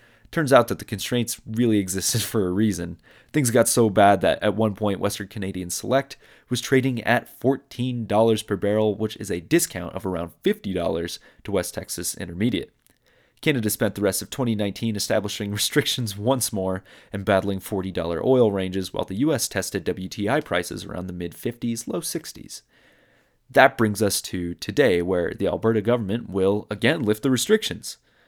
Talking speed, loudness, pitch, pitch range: 170 wpm, -23 LUFS, 105 Hz, 95-120 Hz